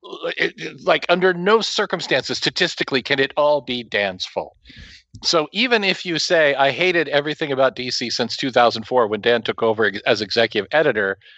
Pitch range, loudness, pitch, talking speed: 125-180 Hz, -19 LUFS, 150 Hz, 160 wpm